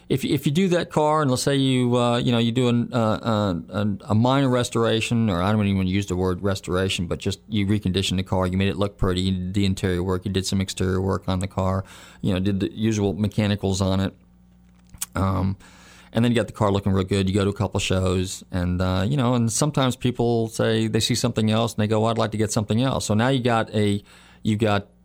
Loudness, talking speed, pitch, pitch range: -23 LUFS, 255 wpm, 100 Hz, 95-115 Hz